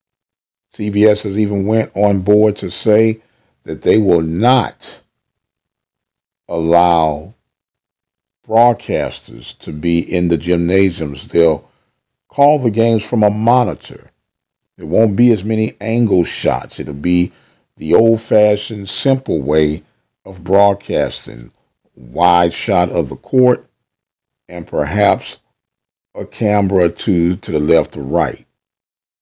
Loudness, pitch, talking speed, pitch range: -15 LUFS, 100 Hz, 120 wpm, 85-110 Hz